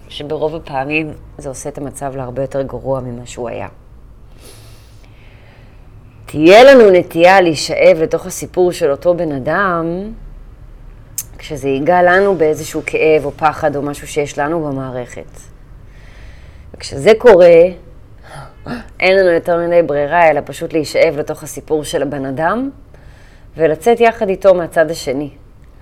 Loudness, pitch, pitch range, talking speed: -13 LUFS, 145 Hz, 120-165 Hz, 125 wpm